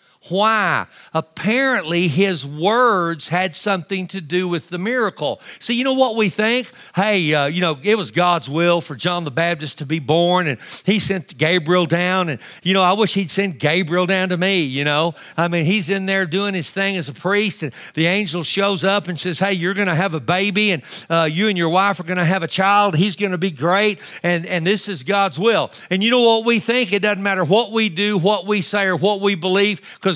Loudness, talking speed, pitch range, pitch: -18 LUFS, 235 wpm, 175-205 Hz, 190 Hz